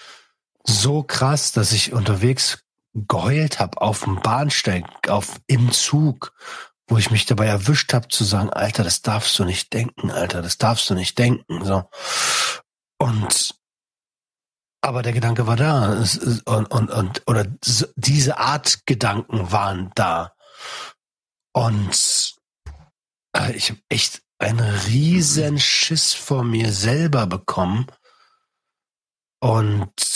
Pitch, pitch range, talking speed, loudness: 115 Hz, 105-135 Hz, 120 wpm, -19 LUFS